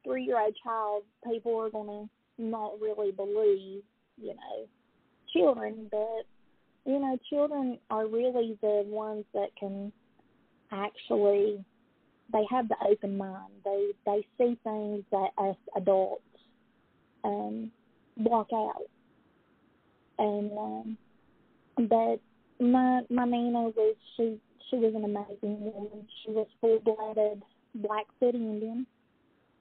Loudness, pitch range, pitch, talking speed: -31 LUFS, 205-235 Hz, 215 Hz, 110 wpm